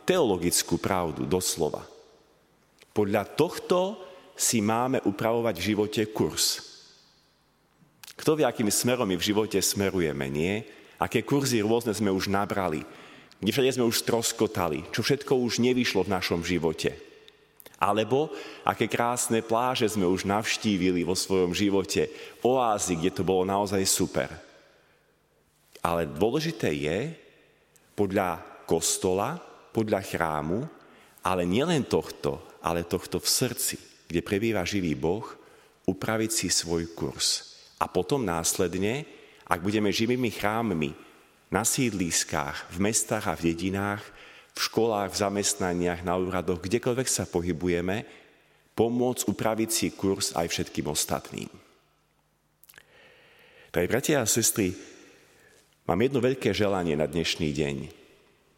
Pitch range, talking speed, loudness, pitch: 90-115 Hz, 120 wpm, -27 LUFS, 105 Hz